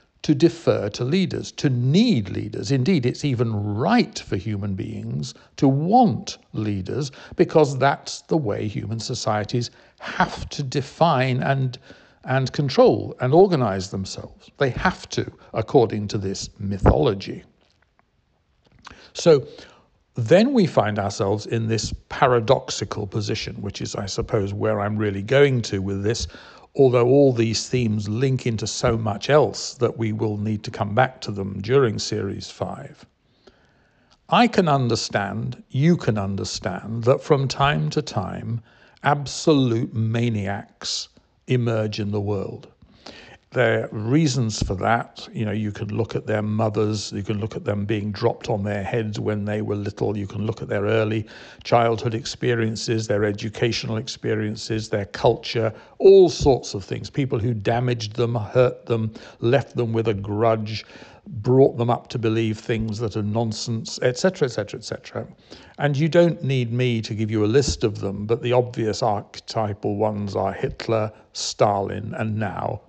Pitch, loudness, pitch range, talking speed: 115 Hz, -22 LUFS, 105-130 Hz, 150 wpm